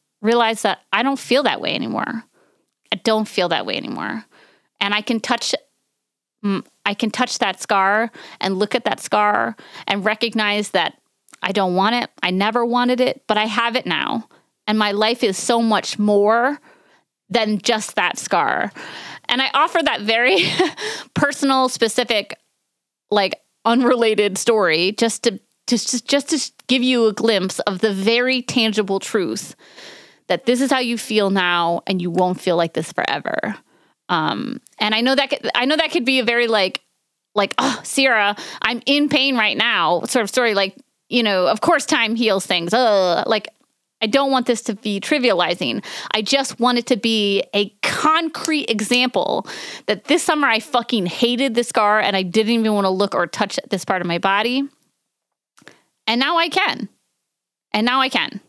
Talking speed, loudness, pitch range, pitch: 175 wpm, -18 LUFS, 205-255 Hz, 230 Hz